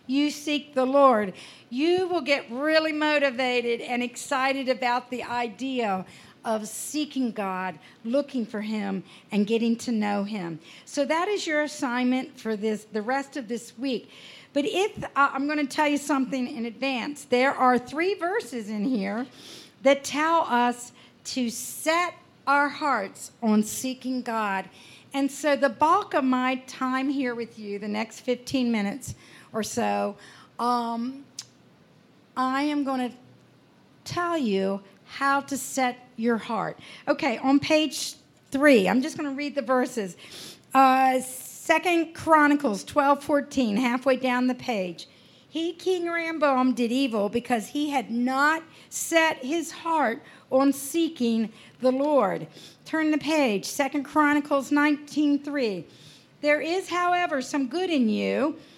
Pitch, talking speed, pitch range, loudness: 265 Hz, 145 wpm, 235-295 Hz, -25 LUFS